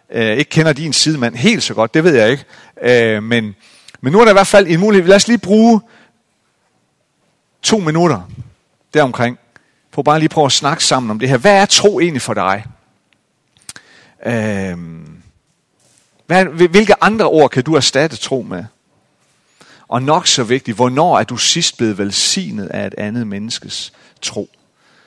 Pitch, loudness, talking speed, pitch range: 150 Hz, -13 LUFS, 160 wpm, 120-190 Hz